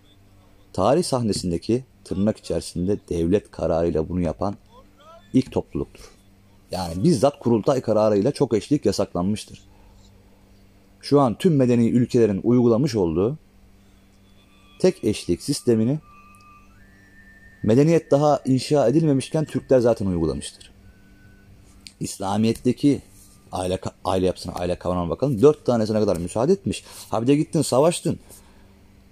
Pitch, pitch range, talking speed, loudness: 100 Hz, 95-125 Hz, 105 wpm, -22 LUFS